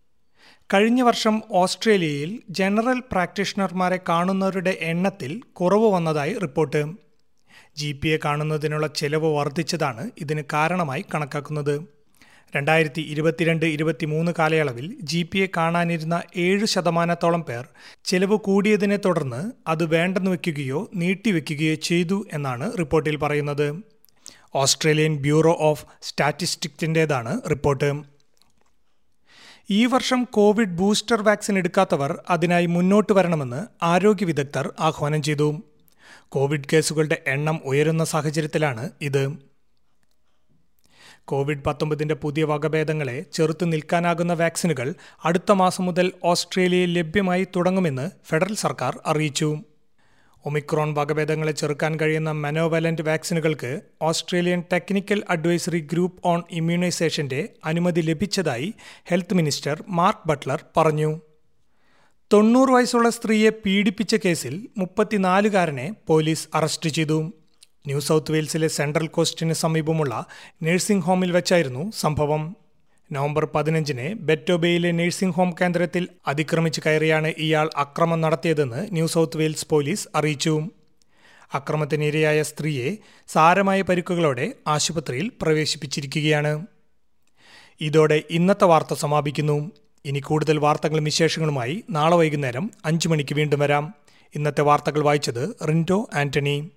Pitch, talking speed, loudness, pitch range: 160 Hz, 100 wpm, -22 LUFS, 155-185 Hz